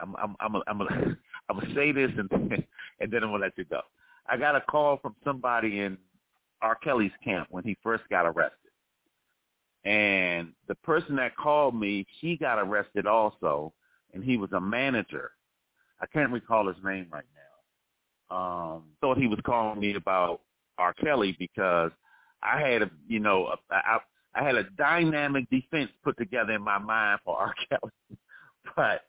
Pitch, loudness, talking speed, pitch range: 110 Hz, -28 LUFS, 175 wpm, 95-145 Hz